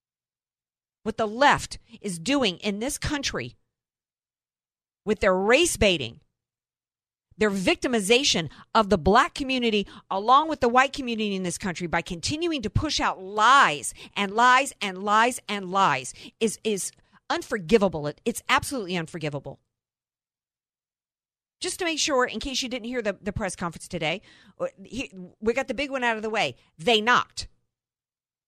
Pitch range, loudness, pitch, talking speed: 180-250 Hz, -24 LUFS, 210 Hz, 145 wpm